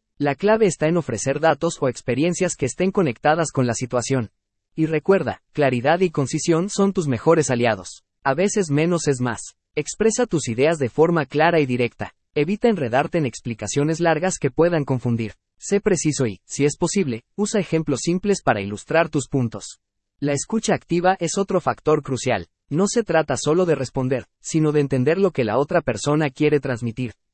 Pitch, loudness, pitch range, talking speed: 150 Hz, -21 LUFS, 125-170 Hz, 175 wpm